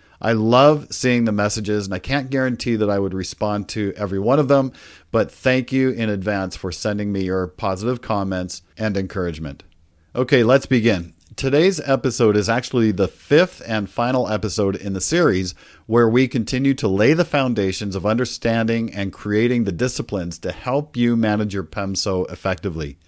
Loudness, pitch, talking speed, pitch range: -20 LUFS, 105 Hz, 170 wpm, 95-125 Hz